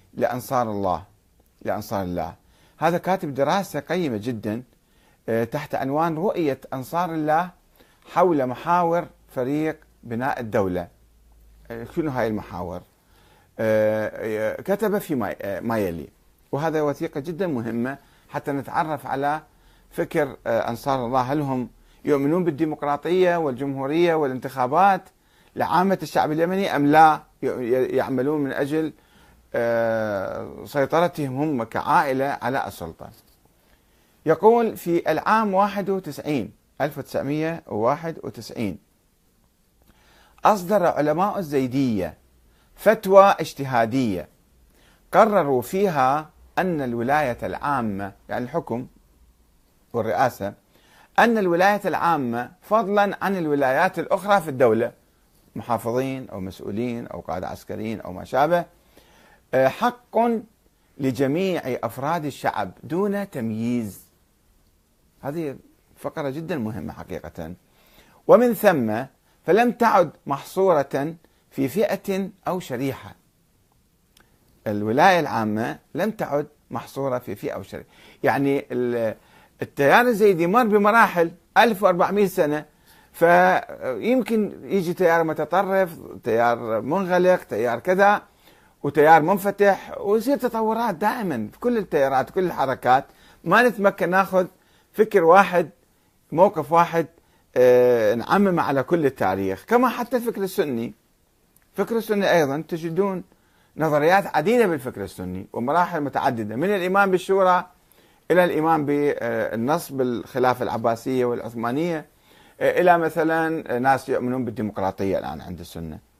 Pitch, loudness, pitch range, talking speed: 150 Hz, -22 LUFS, 120-185 Hz, 95 wpm